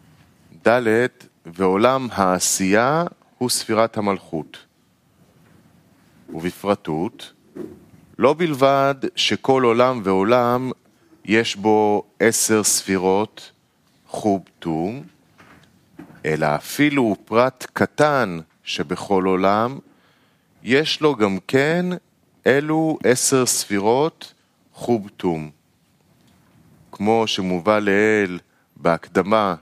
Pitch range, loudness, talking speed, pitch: 95-130 Hz, -19 LUFS, 75 wpm, 110 Hz